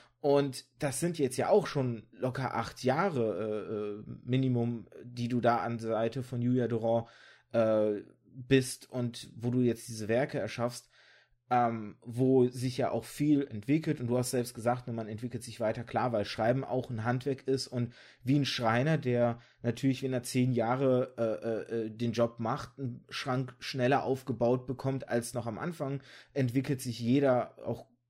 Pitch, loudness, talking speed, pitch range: 125 Hz, -32 LUFS, 175 wpm, 115-130 Hz